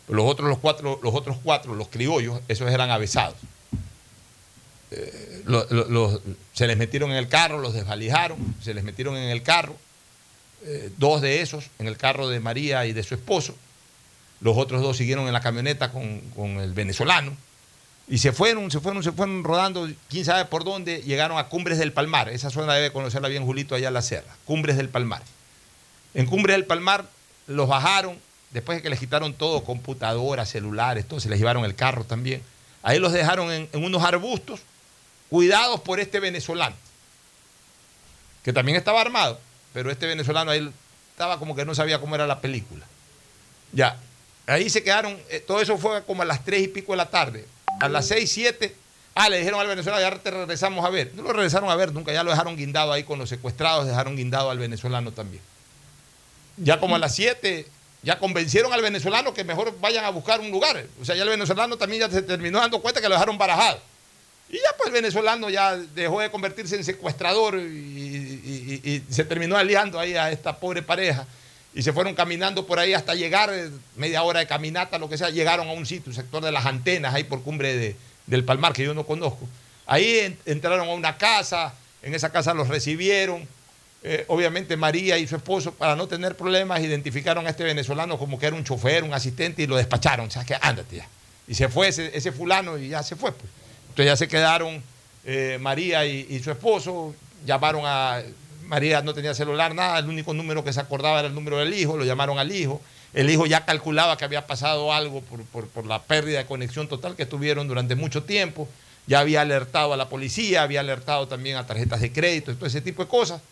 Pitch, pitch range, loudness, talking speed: 150 Hz, 130-175 Hz, -23 LUFS, 205 wpm